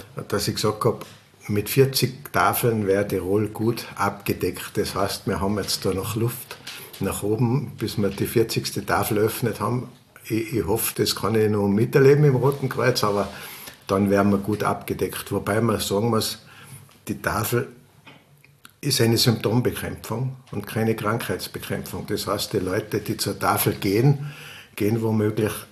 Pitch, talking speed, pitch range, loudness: 110 Hz, 160 wpm, 100-125 Hz, -23 LUFS